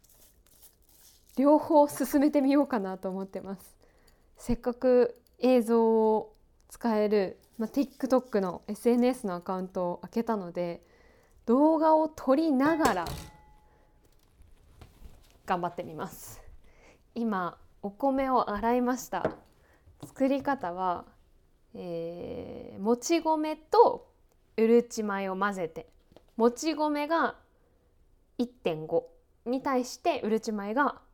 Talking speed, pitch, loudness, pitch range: 210 characters per minute, 235 Hz, -28 LUFS, 195-270 Hz